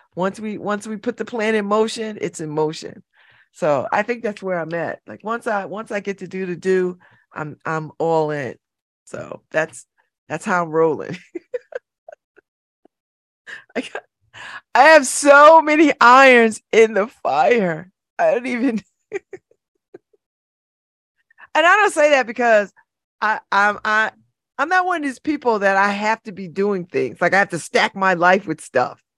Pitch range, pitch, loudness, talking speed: 180-255 Hz, 215 Hz, -17 LUFS, 170 wpm